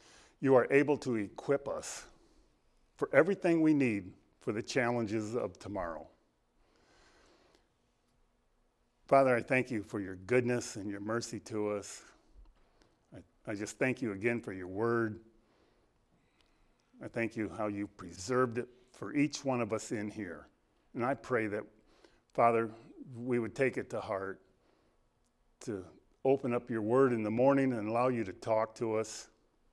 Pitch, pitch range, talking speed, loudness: 115 Hz, 105-125 Hz, 155 wpm, -33 LUFS